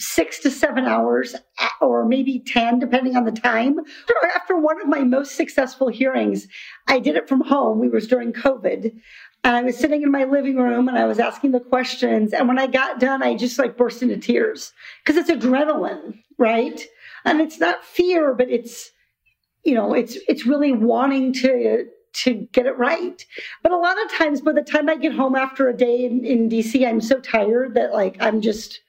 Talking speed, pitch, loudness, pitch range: 200 wpm, 260 Hz, -19 LUFS, 240-290 Hz